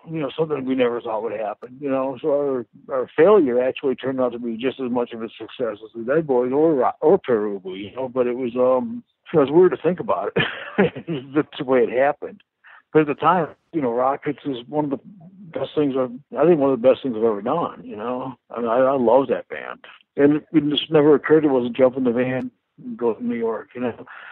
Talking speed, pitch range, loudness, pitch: 255 wpm, 125-150 Hz, -21 LUFS, 130 Hz